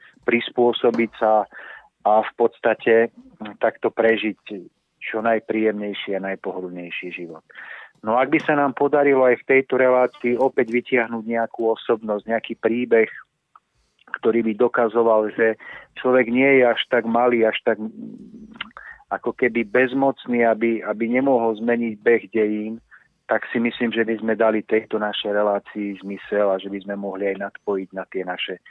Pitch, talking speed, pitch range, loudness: 115 Hz, 145 wpm, 105-125 Hz, -21 LUFS